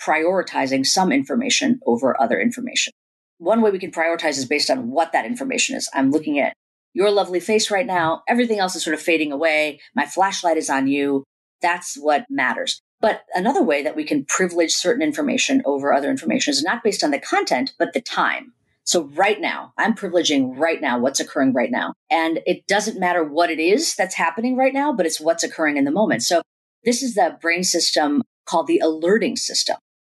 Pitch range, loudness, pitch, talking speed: 165-255 Hz, -20 LUFS, 185 Hz, 200 wpm